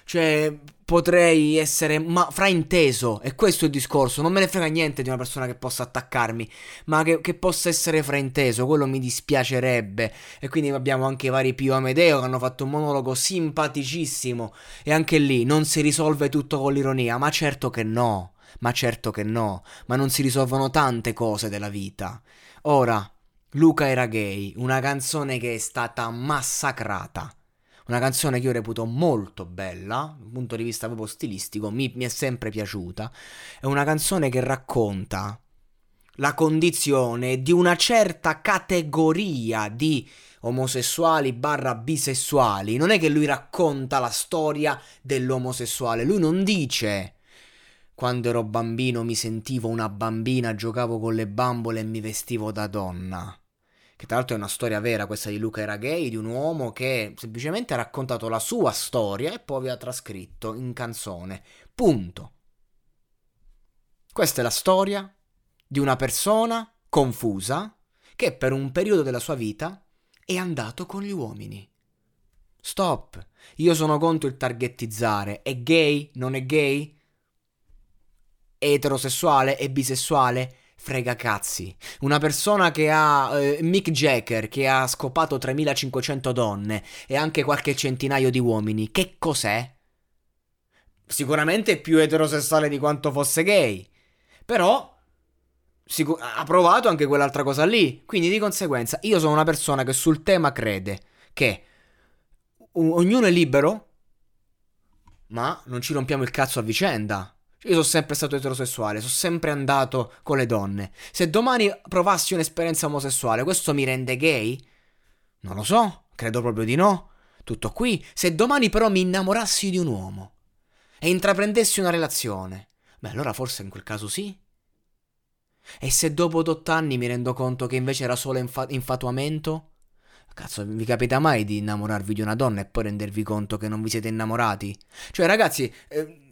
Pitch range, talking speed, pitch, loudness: 115-155 Hz, 155 wpm, 130 Hz, -23 LUFS